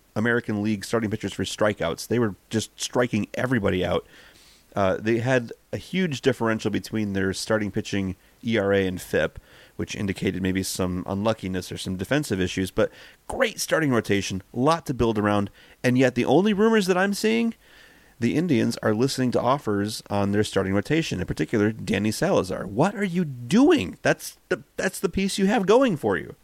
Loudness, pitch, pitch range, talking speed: -24 LUFS, 110 Hz, 100-140 Hz, 180 wpm